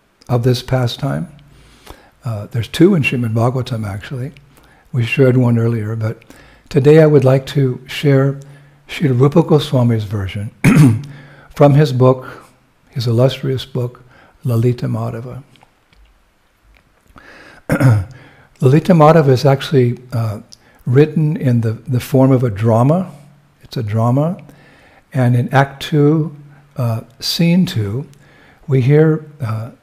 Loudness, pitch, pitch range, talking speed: -14 LUFS, 130 Hz, 120-145 Hz, 115 wpm